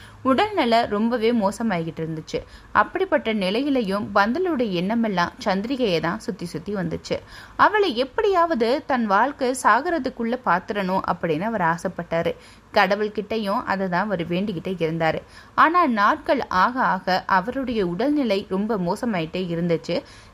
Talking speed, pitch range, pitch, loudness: 105 wpm, 175-250 Hz, 205 Hz, -22 LUFS